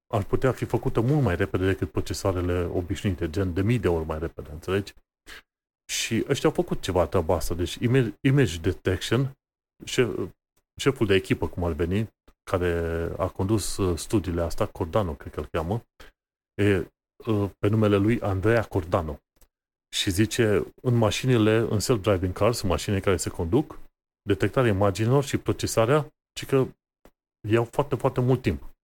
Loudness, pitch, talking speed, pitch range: -25 LUFS, 100 Hz, 150 wpm, 90-115 Hz